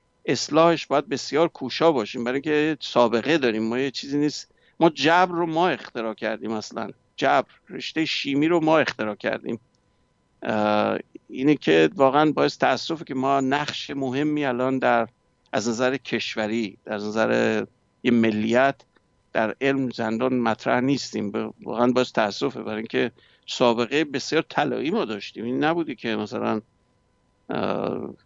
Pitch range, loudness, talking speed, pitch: 110-150 Hz, -23 LUFS, 135 wpm, 125 Hz